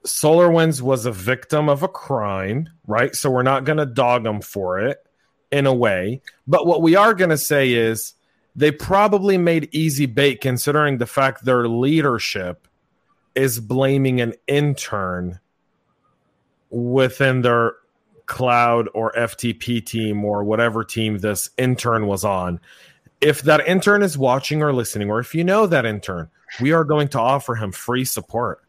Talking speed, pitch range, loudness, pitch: 160 wpm, 115-150 Hz, -19 LUFS, 130 Hz